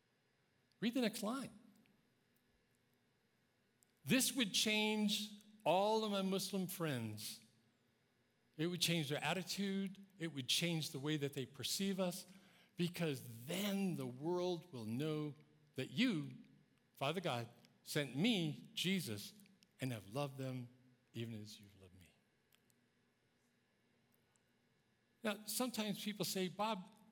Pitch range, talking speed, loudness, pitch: 125-200 Hz, 115 wpm, -41 LUFS, 170 Hz